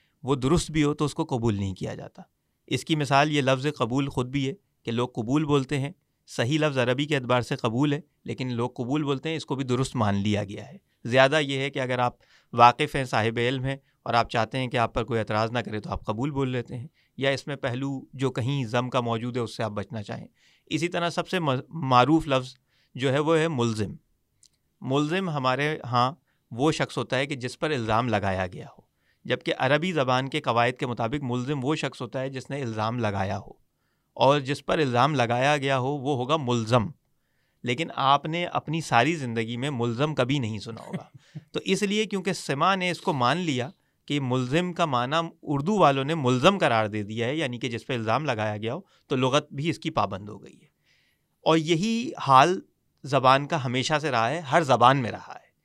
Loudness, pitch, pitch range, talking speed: -25 LUFS, 135 Hz, 120-150 Hz, 220 wpm